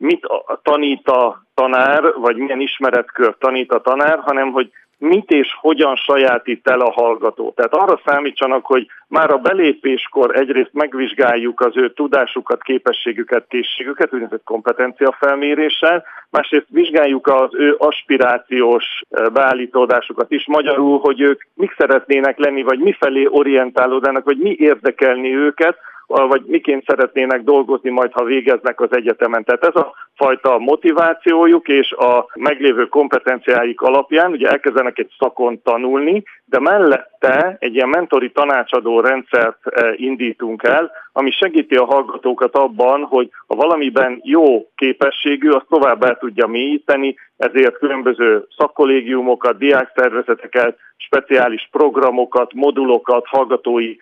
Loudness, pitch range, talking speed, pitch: -15 LUFS, 125-150 Hz, 125 wpm, 135 Hz